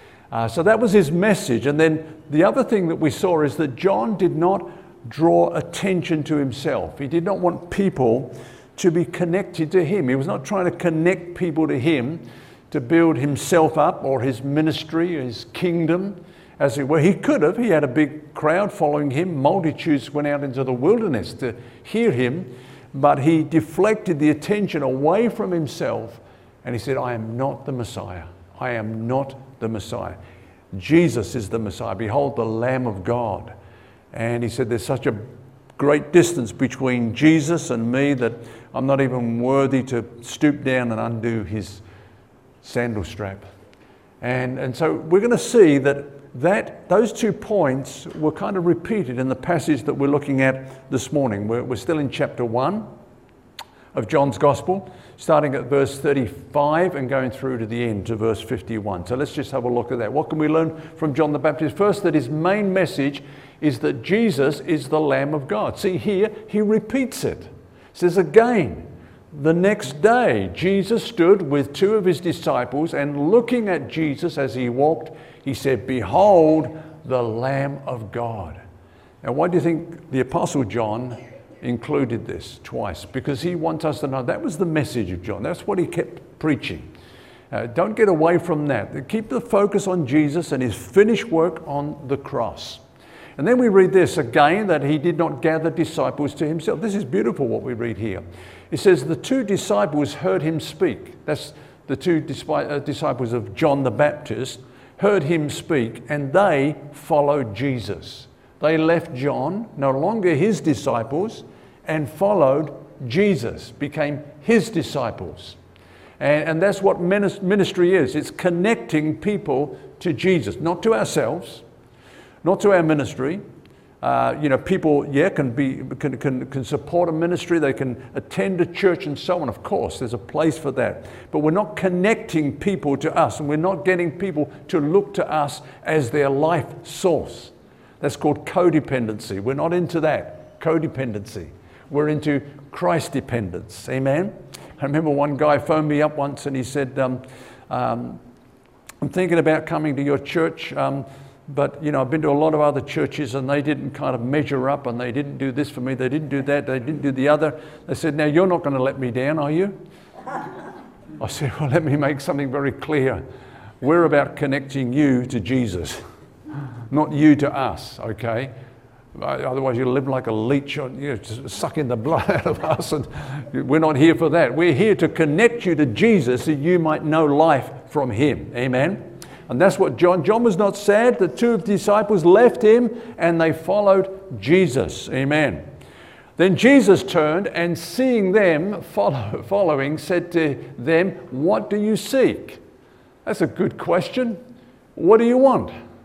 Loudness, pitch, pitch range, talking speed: -20 LUFS, 150 Hz, 130-170 Hz, 180 wpm